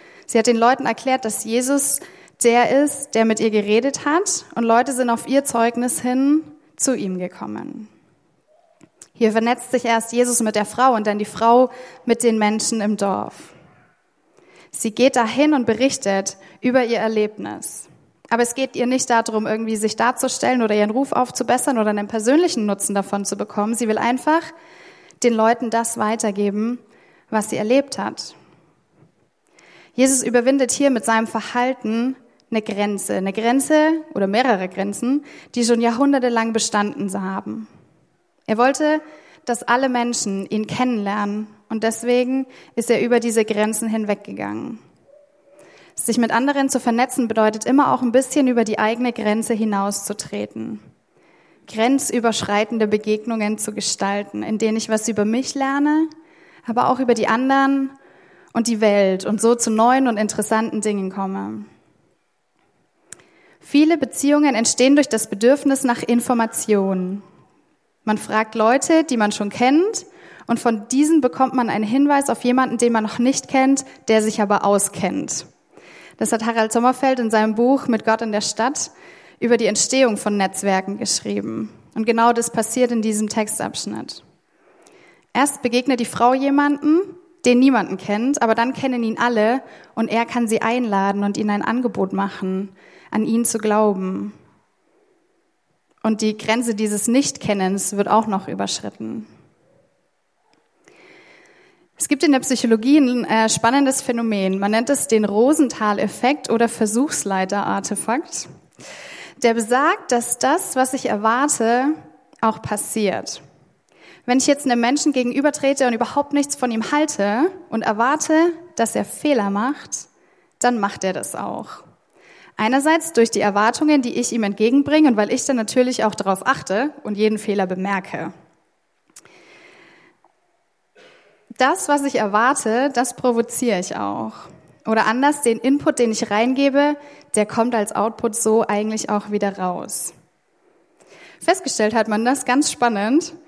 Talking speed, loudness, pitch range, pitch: 145 wpm, -19 LUFS, 215-270 Hz, 235 Hz